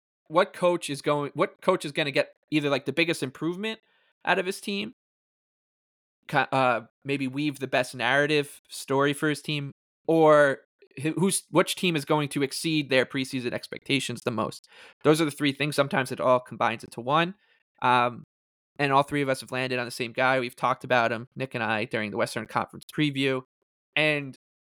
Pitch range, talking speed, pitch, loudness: 125-155 Hz, 190 wpm, 140 Hz, -26 LUFS